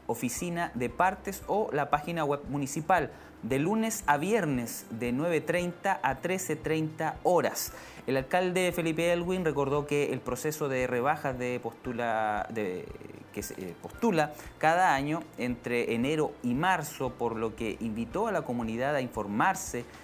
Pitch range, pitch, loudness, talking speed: 125-175 Hz, 145 Hz, -30 LUFS, 145 wpm